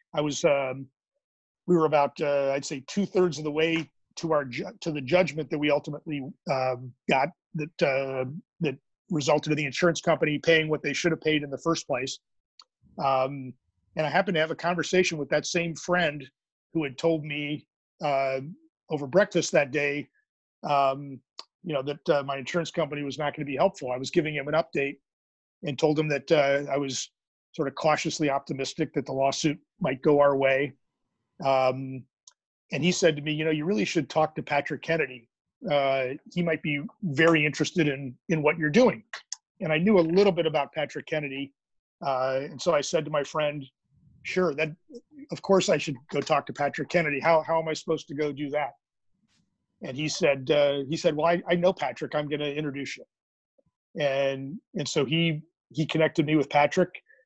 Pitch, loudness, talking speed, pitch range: 150 Hz, -27 LUFS, 200 wpm, 140-165 Hz